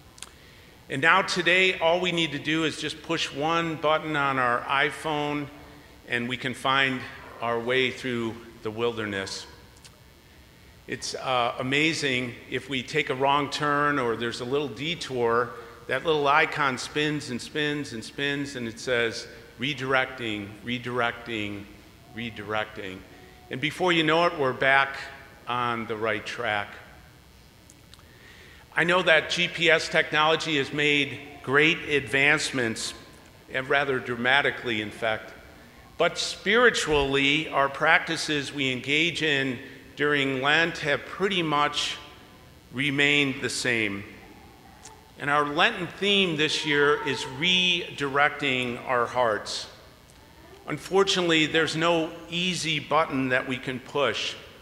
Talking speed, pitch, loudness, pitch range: 125 wpm, 140 Hz, -25 LUFS, 125-155 Hz